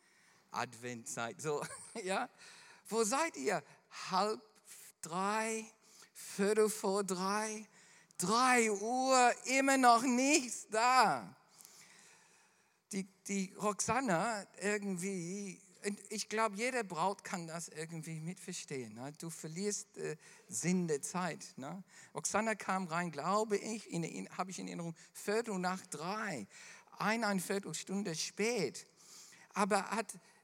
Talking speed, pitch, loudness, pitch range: 105 wpm, 200 Hz, -36 LUFS, 180-220 Hz